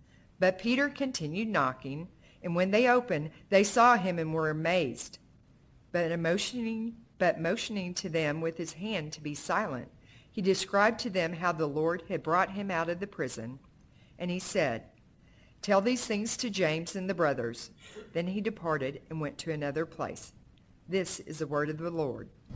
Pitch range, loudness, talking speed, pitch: 155-200 Hz, -30 LUFS, 175 wpm, 175 Hz